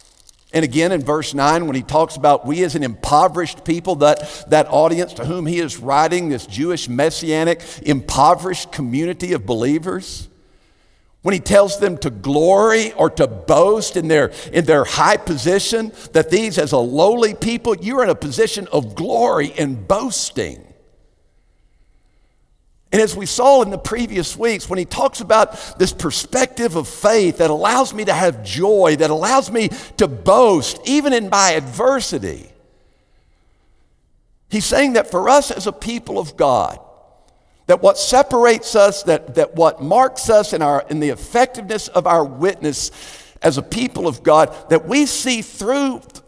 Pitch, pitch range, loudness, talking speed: 175 Hz, 150-220 Hz, -16 LUFS, 160 wpm